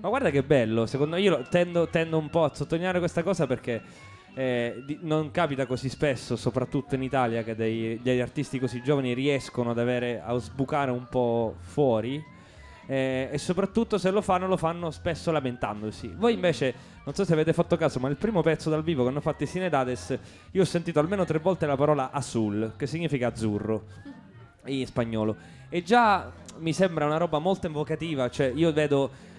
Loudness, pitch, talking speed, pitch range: -27 LUFS, 145 Hz, 190 wpm, 125-165 Hz